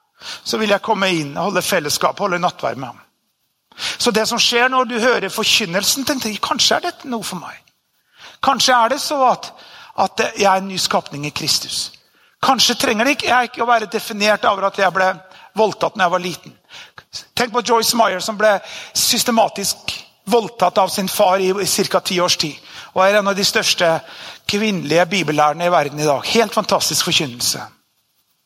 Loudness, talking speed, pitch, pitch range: -17 LUFS, 190 wpm, 200 Hz, 180-230 Hz